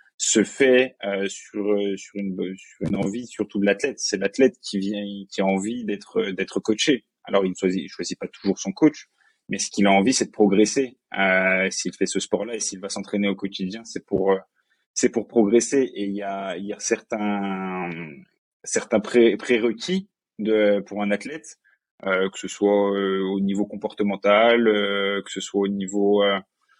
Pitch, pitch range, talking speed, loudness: 100 Hz, 100-110 Hz, 200 wpm, -23 LUFS